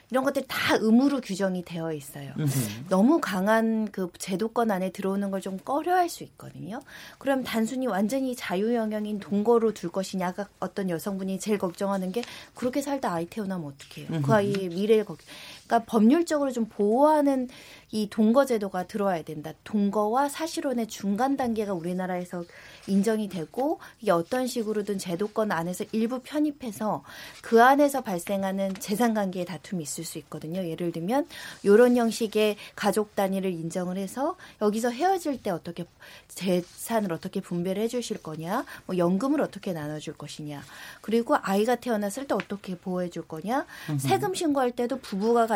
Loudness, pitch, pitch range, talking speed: -27 LUFS, 205 Hz, 180-240 Hz, 360 characters per minute